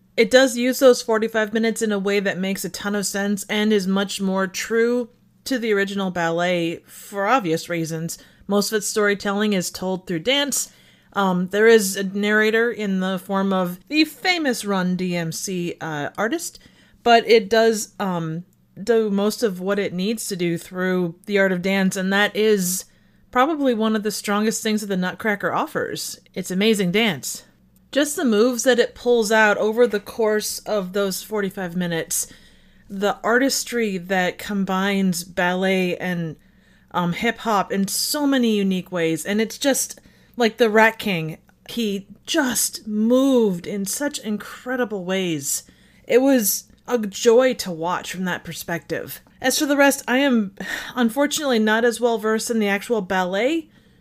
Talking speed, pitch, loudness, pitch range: 165 wpm, 205 Hz, -21 LUFS, 190-230 Hz